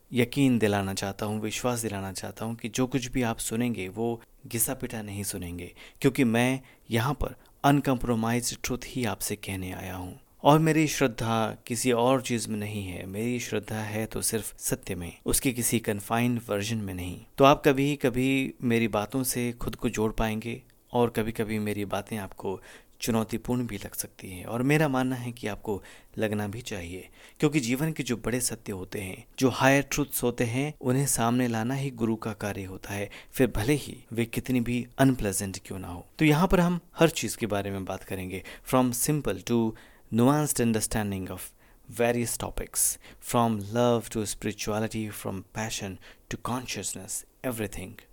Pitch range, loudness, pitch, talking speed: 105-125 Hz, -28 LUFS, 115 Hz, 175 wpm